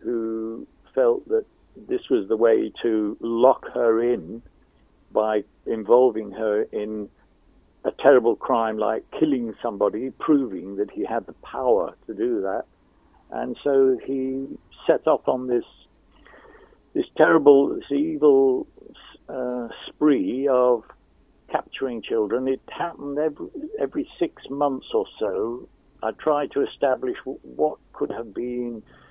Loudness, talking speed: -23 LUFS, 130 wpm